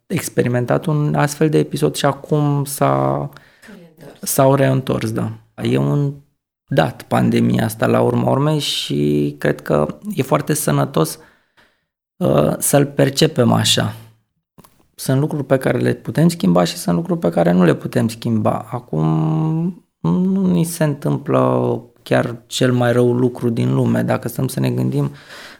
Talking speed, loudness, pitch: 145 wpm, -17 LUFS, 120 Hz